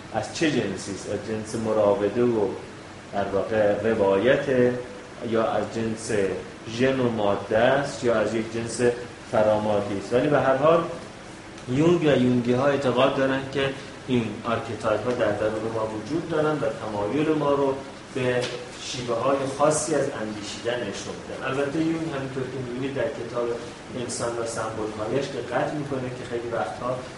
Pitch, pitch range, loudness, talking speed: 120 Hz, 110-135 Hz, -25 LUFS, 155 wpm